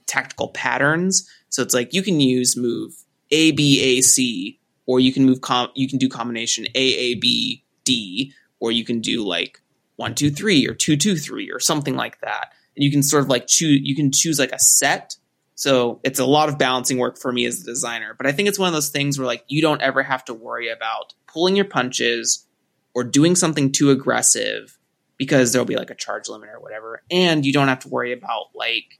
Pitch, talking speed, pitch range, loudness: 135 Hz, 225 wpm, 125-155 Hz, -19 LUFS